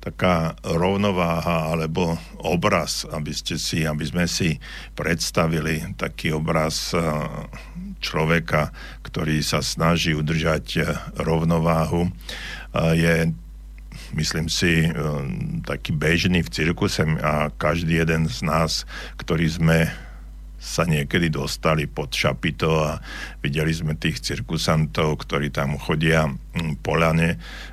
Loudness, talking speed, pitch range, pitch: -22 LUFS, 105 wpm, 80-85 Hz, 80 Hz